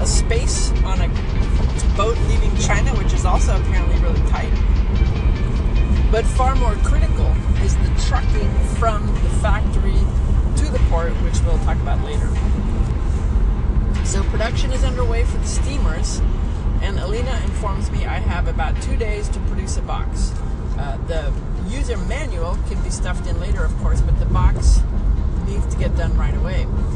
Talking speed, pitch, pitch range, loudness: 160 wpm, 70 Hz, 65-80 Hz, -20 LUFS